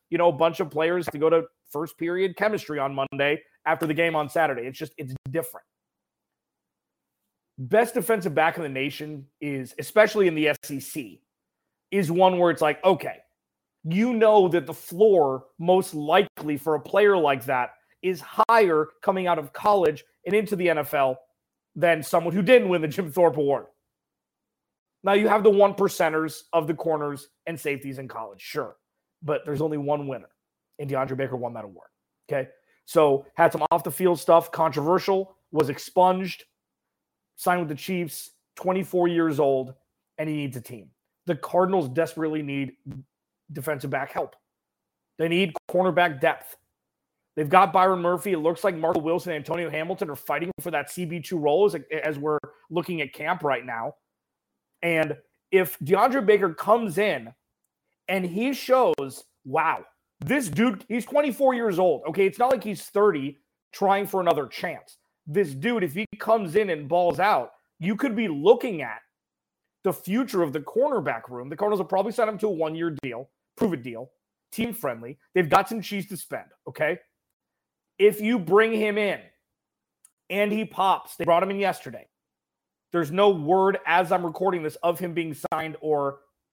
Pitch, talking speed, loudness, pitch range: 170 Hz, 170 wpm, -24 LUFS, 150-195 Hz